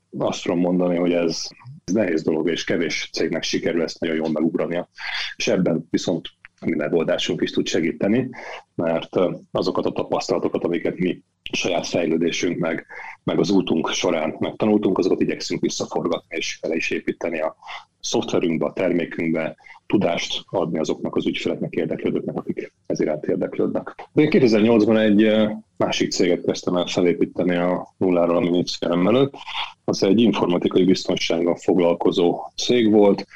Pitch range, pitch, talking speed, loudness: 85-110 Hz, 90 Hz, 140 wpm, -21 LUFS